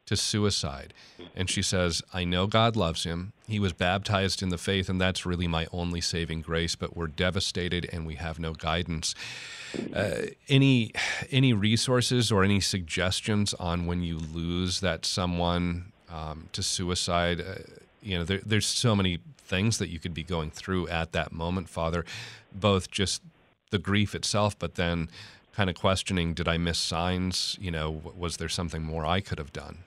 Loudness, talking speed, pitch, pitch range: -28 LUFS, 180 wpm, 90 Hz, 85-100 Hz